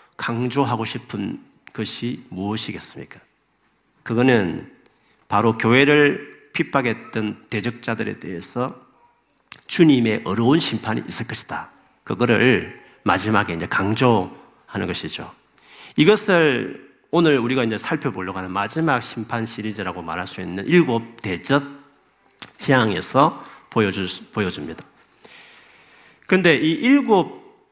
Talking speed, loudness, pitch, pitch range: 260 characters per minute, -20 LUFS, 120 Hz, 110-150 Hz